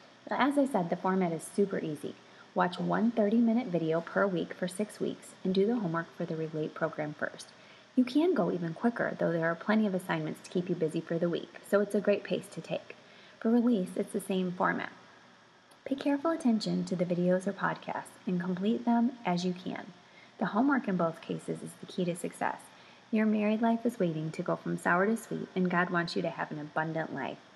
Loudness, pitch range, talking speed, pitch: -31 LUFS, 170-220 Hz, 220 wpm, 190 Hz